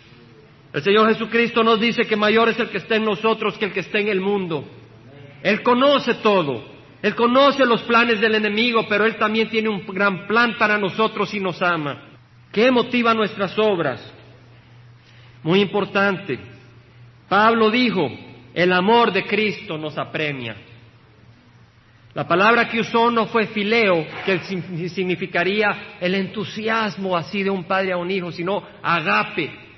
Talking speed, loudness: 150 wpm, -19 LUFS